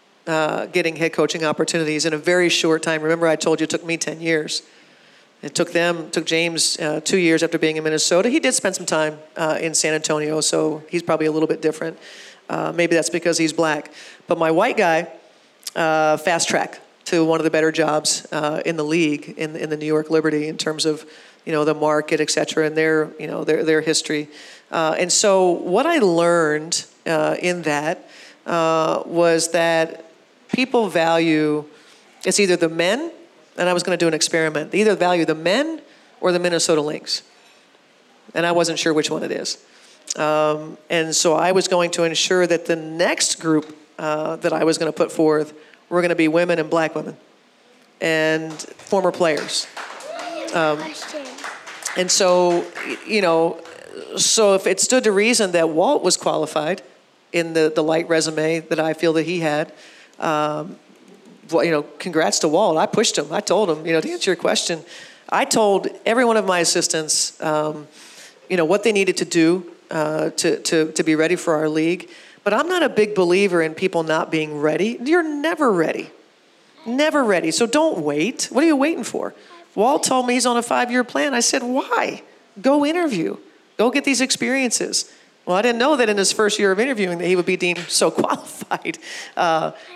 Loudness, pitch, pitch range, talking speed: -19 LUFS, 165 Hz, 155-190 Hz, 200 wpm